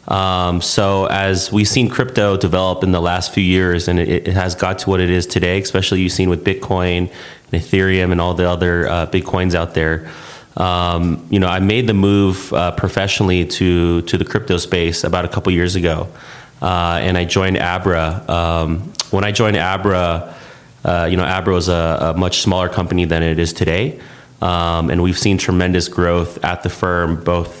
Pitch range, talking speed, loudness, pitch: 85-95 Hz, 200 wpm, -16 LUFS, 90 Hz